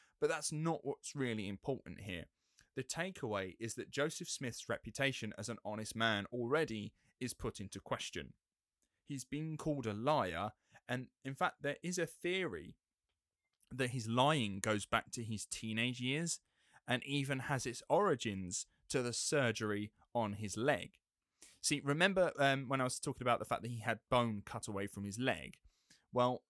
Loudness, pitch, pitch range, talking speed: -38 LUFS, 125 Hz, 110-145 Hz, 170 wpm